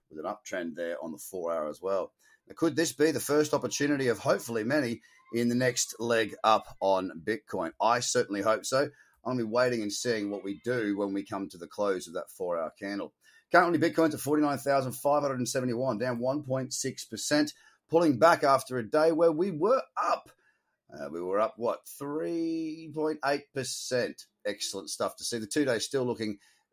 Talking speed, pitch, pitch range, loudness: 180 wpm, 135 Hz, 120-155 Hz, -29 LUFS